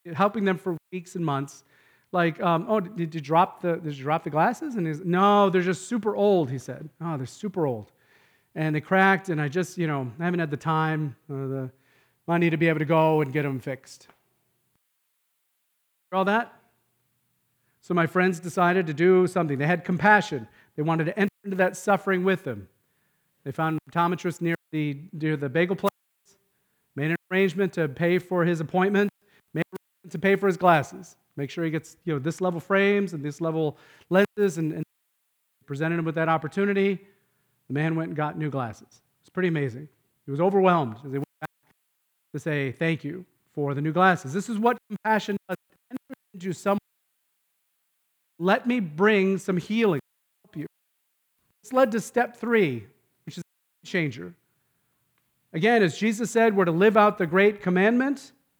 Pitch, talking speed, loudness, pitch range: 170 Hz, 185 wpm, -25 LUFS, 150-195 Hz